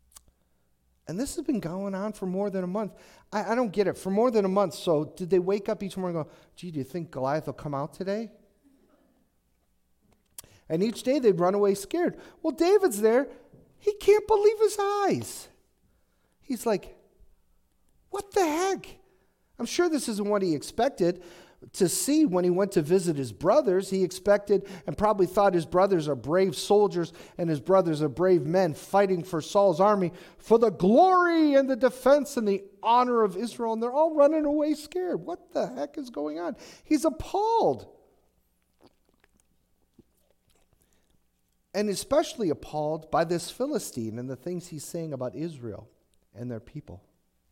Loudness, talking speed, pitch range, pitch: -26 LUFS, 170 wpm, 170-255 Hz, 195 Hz